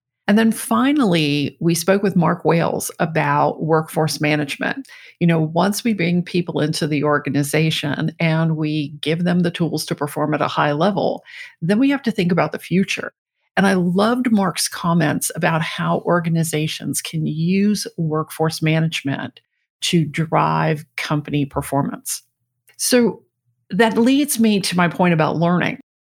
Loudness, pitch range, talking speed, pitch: -19 LUFS, 150-195 Hz, 150 wpm, 165 Hz